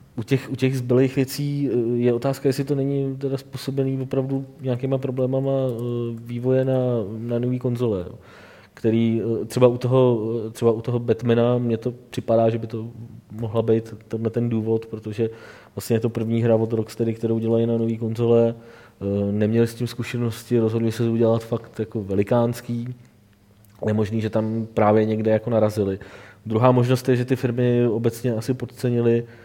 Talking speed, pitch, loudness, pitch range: 165 wpm, 115 Hz, -22 LUFS, 115-125 Hz